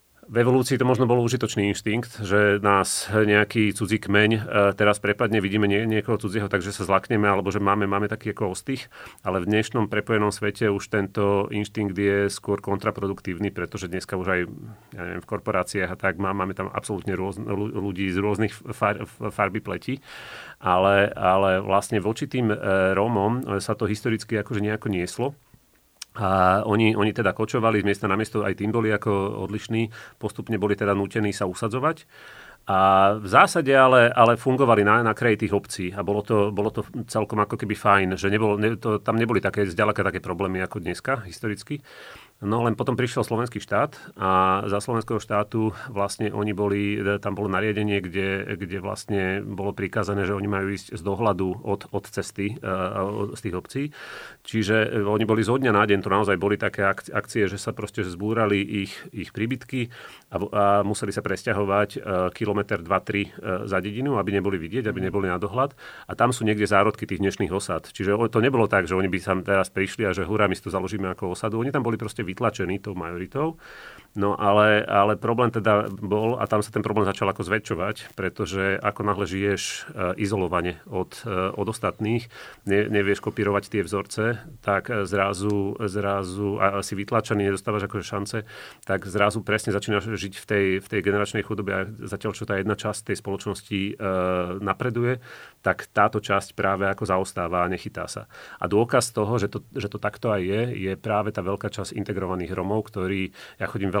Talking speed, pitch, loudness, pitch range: 180 wpm, 105 Hz, -24 LUFS, 100-110 Hz